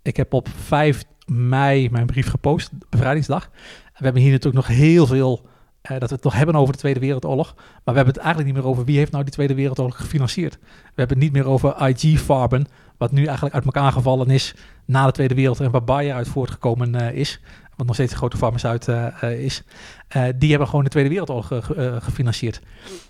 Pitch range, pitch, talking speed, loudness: 125-140 Hz, 135 Hz, 215 wpm, -19 LUFS